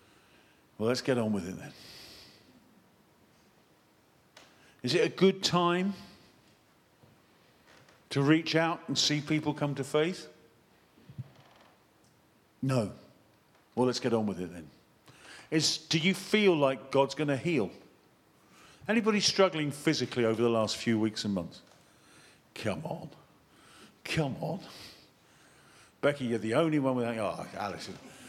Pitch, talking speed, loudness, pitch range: 140 Hz, 130 wpm, -30 LUFS, 115-160 Hz